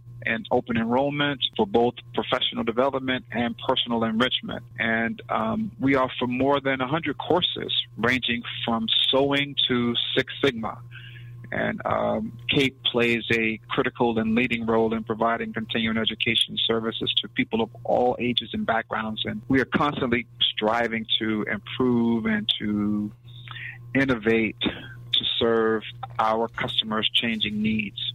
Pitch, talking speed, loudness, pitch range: 120 Hz, 130 wpm, -24 LUFS, 115-125 Hz